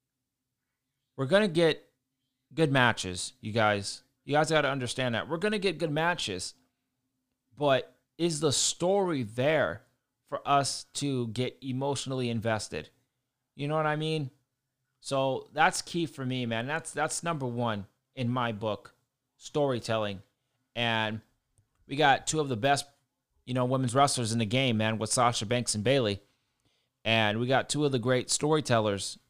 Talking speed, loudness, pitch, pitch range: 155 wpm, -29 LUFS, 130 Hz, 120-140 Hz